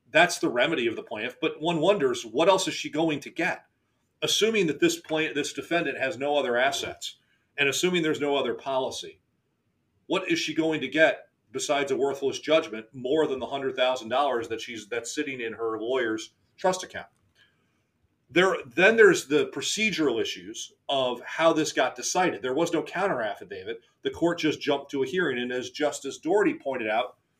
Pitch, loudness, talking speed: 155 Hz, -26 LUFS, 190 wpm